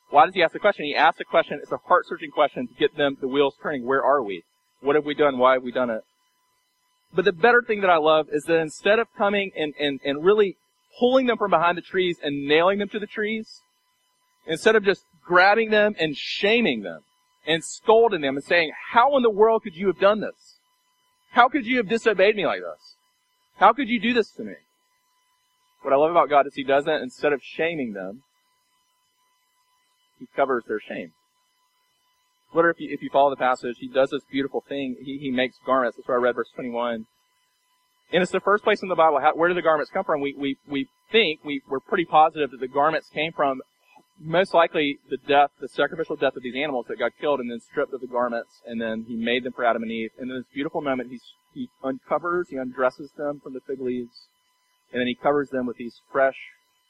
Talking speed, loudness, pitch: 225 wpm, -23 LUFS, 175 Hz